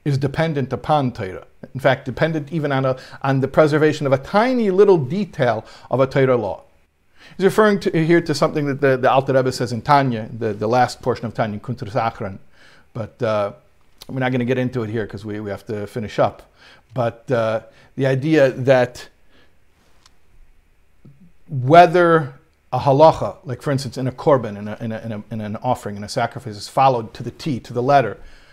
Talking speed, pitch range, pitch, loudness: 200 wpm, 115-145 Hz, 130 Hz, -19 LUFS